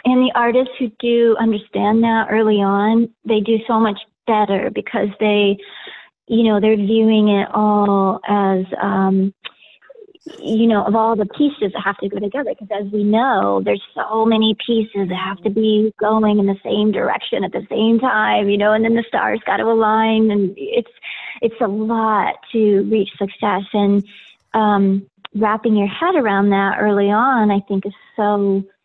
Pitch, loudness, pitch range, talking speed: 215 Hz, -17 LUFS, 200-225 Hz, 180 wpm